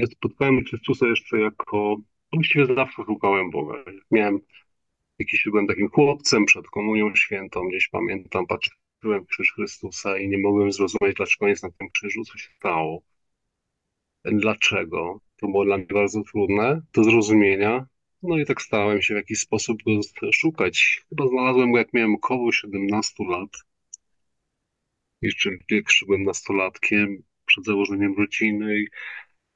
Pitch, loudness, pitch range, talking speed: 105 Hz, -22 LUFS, 100-120 Hz, 140 wpm